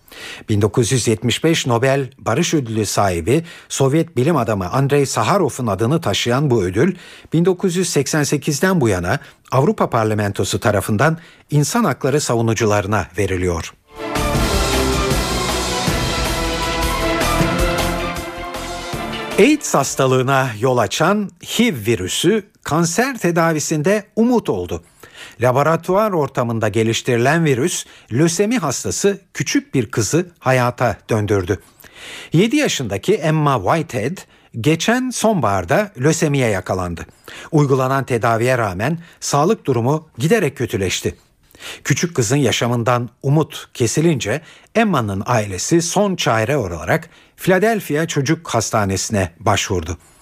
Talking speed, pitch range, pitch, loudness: 90 wpm, 110-165 Hz, 135 Hz, -18 LUFS